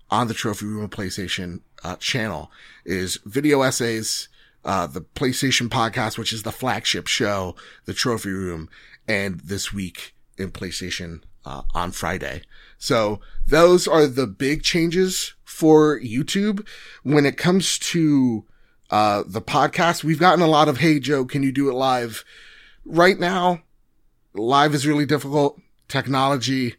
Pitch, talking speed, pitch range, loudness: 130 Hz, 145 wpm, 105-150 Hz, -21 LUFS